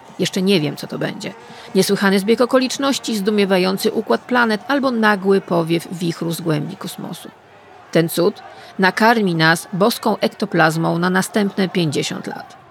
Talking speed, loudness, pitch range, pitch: 135 wpm, -17 LUFS, 175-225 Hz, 195 Hz